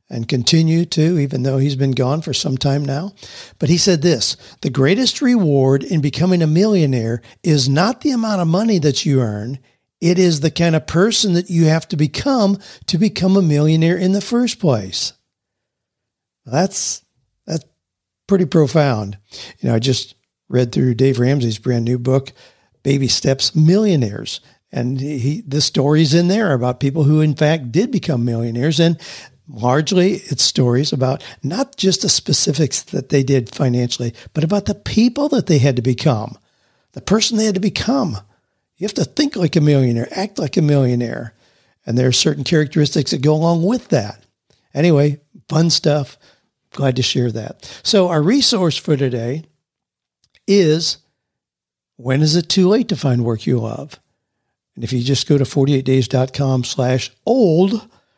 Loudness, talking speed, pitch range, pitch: -16 LUFS, 170 wpm, 130-175 Hz, 150 Hz